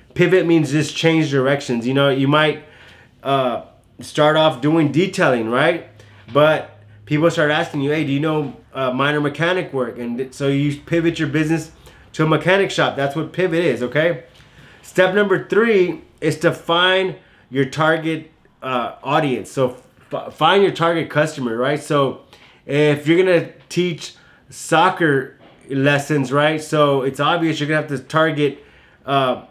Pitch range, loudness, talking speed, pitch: 135-165 Hz, -18 LUFS, 155 wpm, 150 Hz